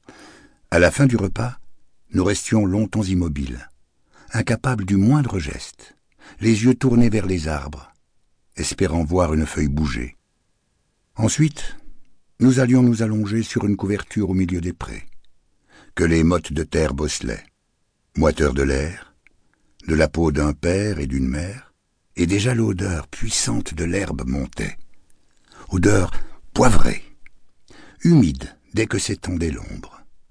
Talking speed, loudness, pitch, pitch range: 135 wpm, -21 LUFS, 90 Hz, 75-110 Hz